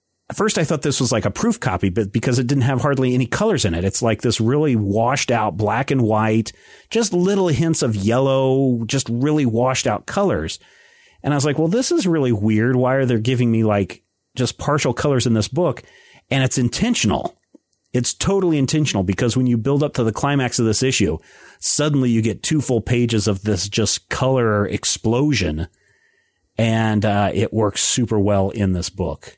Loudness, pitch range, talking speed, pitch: -19 LUFS, 110-140 Hz, 200 wpm, 120 Hz